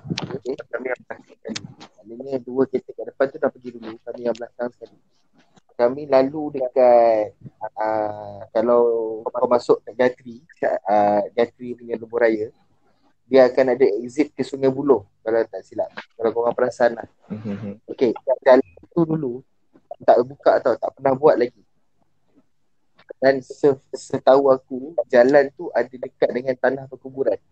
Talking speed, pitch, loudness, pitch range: 145 wpm, 125 Hz, -20 LUFS, 115-135 Hz